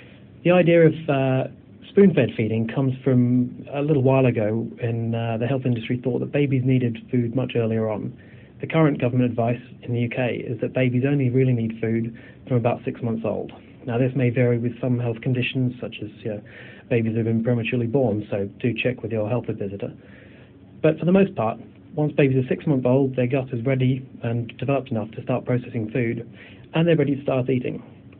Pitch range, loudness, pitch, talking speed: 115-135 Hz, -23 LUFS, 125 Hz, 205 wpm